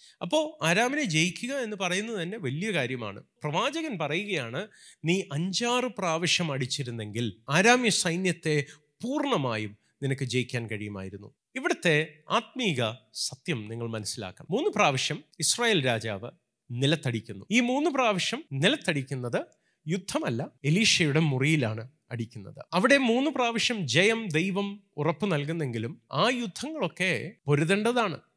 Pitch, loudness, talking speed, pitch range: 165 Hz, -27 LUFS, 100 wpm, 130-215 Hz